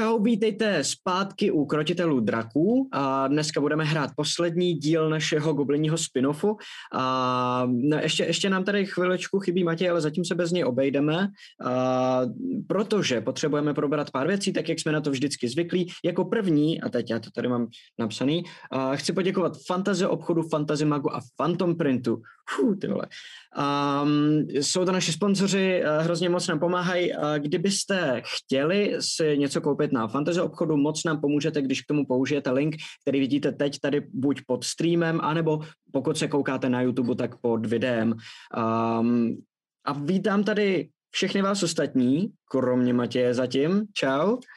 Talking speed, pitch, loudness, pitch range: 155 wpm, 150 Hz, -25 LUFS, 135-180 Hz